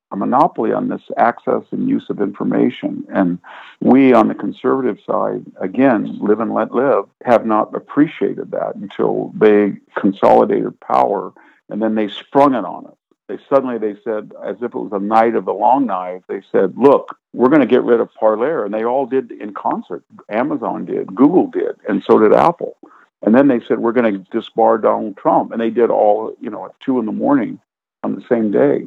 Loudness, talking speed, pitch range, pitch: -16 LUFS, 200 wpm, 105-135 Hz, 115 Hz